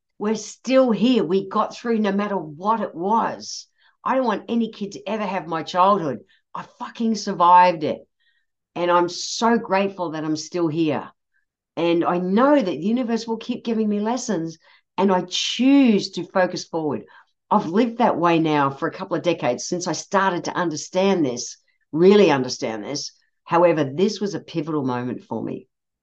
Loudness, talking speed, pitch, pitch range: -21 LUFS, 180 wpm, 185 Hz, 165-220 Hz